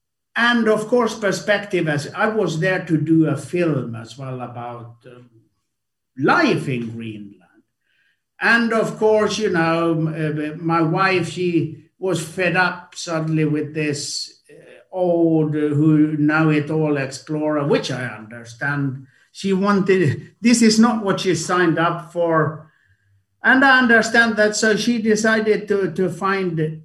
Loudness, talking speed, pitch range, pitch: -18 LUFS, 145 wpm, 150-200 Hz, 165 Hz